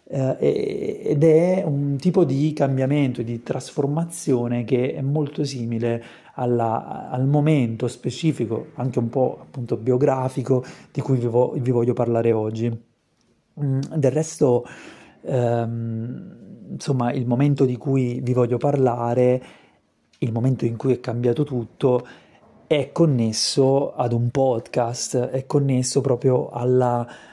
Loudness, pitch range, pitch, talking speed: -22 LUFS, 120-145 Hz, 130 Hz, 125 wpm